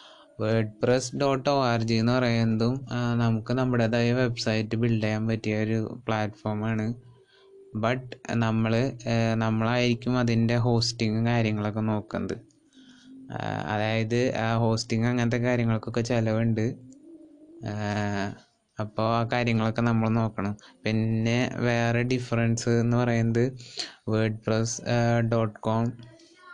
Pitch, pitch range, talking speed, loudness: 115 Hz, 110-125 Hz, 95 wpm, -26 LUFS